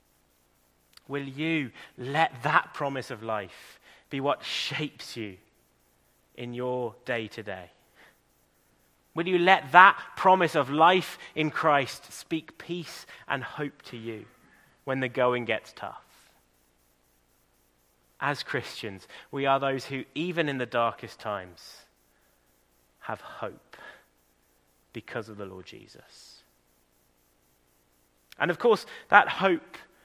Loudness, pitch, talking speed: -27 LUFS, 110 Hz, 120 wpm